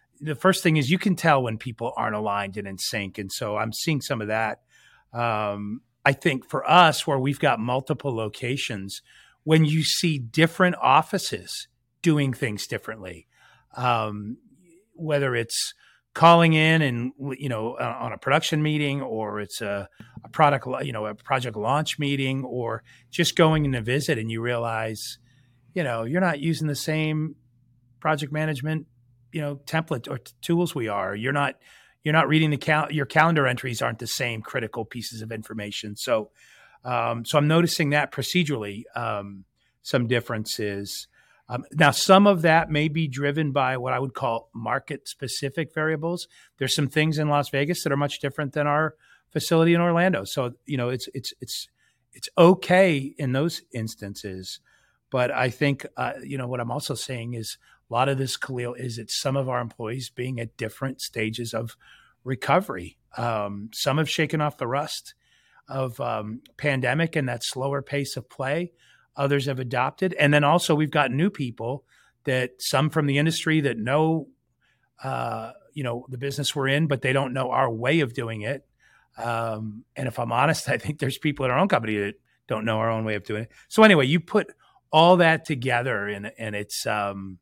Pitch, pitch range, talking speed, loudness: 135 Hz, 115-155 Hz, 185 wpm, -24 LUFS